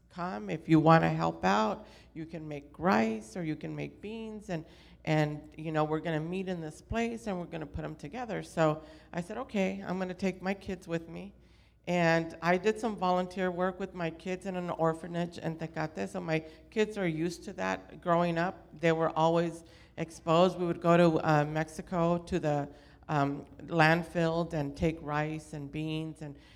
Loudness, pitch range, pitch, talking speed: -31 LUFS, 155-180 Hz, 165 Hz, 200 wpm